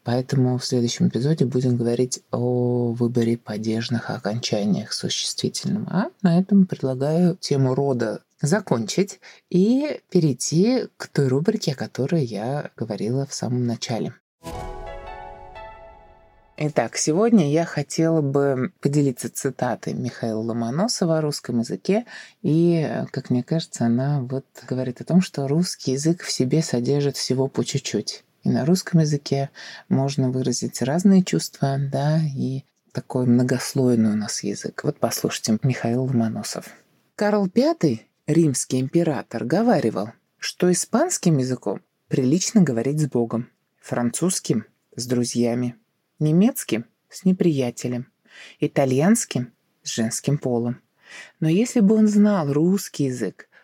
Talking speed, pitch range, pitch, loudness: 120 wpm, 120-170 Hz, 140 Hz, -22 LUFS